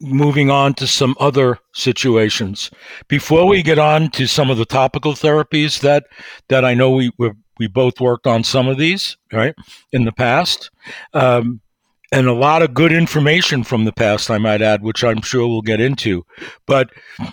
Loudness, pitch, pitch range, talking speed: -15 LUFS, 130 Hz, 115-145 Hz, 185 wpm